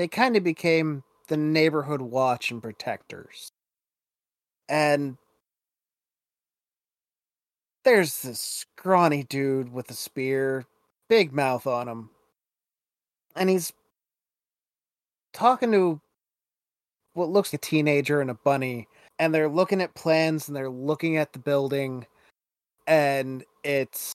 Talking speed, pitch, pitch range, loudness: 115 wpm, 145 Hz, 130-165 Hz, -25 LUFS